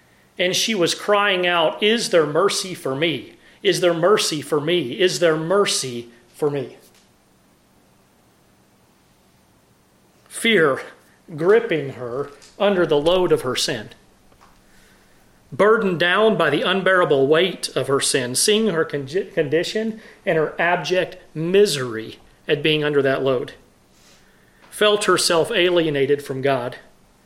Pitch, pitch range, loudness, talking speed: 175 Hz, 150-200 Hz, -19 LUFS, 125 wpm